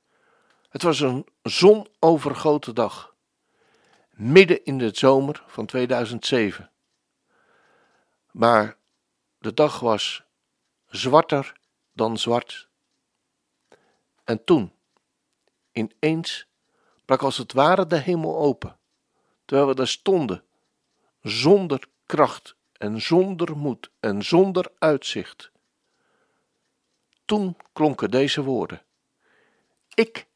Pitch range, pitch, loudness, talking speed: 120-180 Hz, 145 Hz, -22 LUFS, 90 wpm